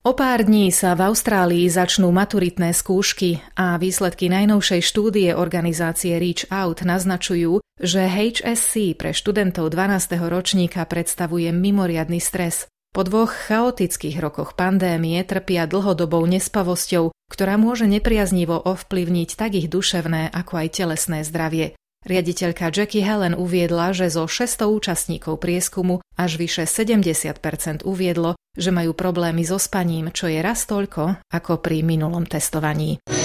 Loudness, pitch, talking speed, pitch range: -20 LUFS, 180 Hz, 130 wpm, 170-195 Hz